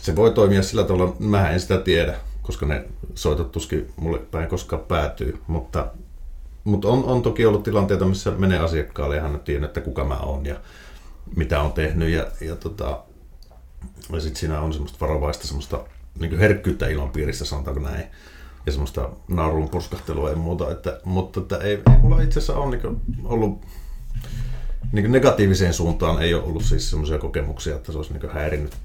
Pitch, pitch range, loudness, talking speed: 80 Hz, 75-95 Hz, -23 LUFS, 180 wpm